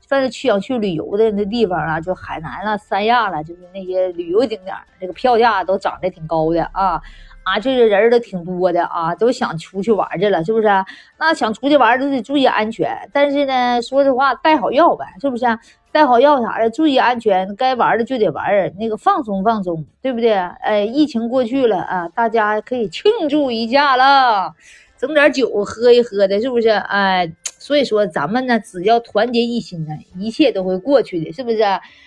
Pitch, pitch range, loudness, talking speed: 225 Hz, 195-260 Hz, -16 LUFS, 300 characters per minute